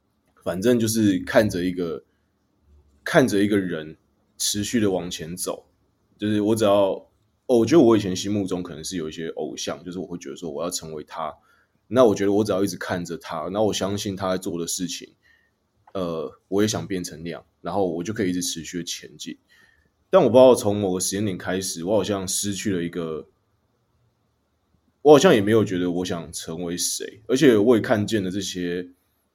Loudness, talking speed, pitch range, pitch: -22 LUFS, 285 characters per minute, 90-105 Hz, 95 Hz